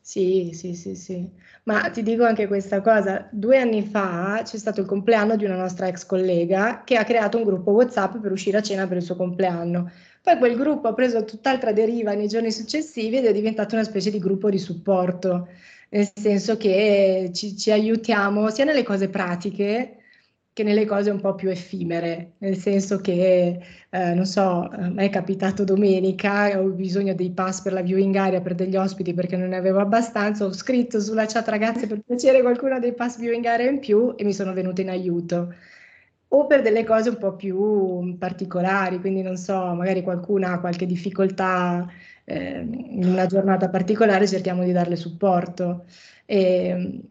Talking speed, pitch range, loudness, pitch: 180 wpm, 185-220 Hz, -22 LUFS, 195 Hz